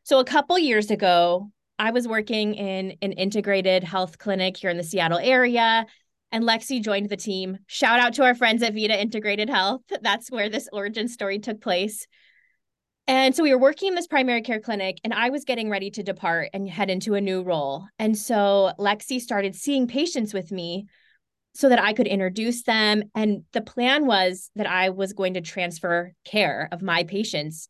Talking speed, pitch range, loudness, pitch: 195 wpm, 190-235 Hz, -23 LUFS, 210 Hz